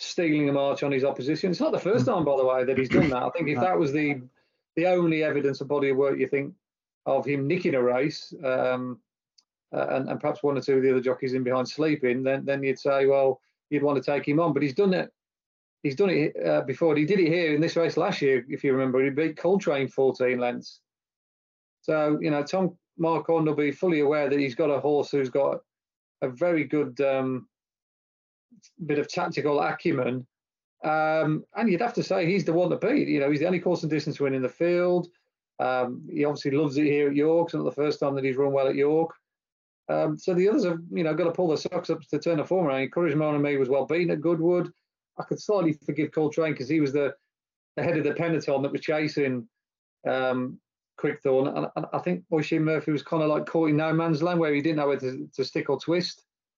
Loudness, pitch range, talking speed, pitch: -26 LUFS, 135-165 Hz, 240 wpm, 145 Hz